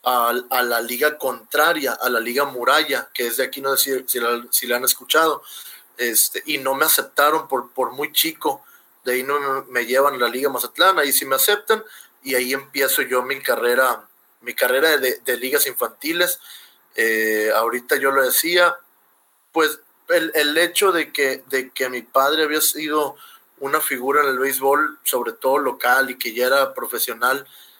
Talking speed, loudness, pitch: 180 wpm, -19 LUFS, 145 Hz